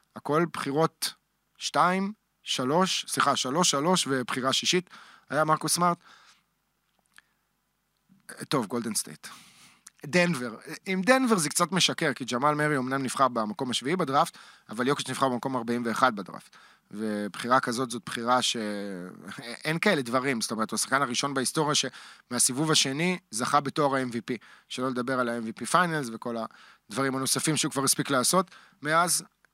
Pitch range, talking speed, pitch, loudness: 125-160 Hz, 135 wpm, 135 Hz, -27 LUFS